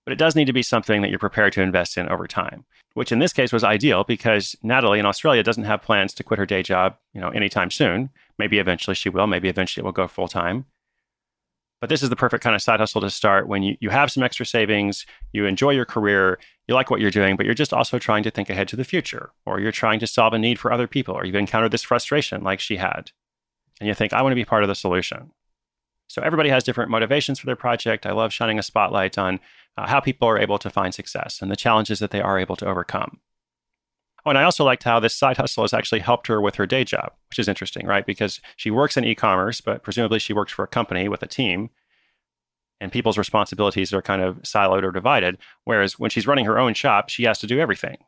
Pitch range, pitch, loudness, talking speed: 100-120 Hz, 110 Hz, -21 LUFS, 255 wpm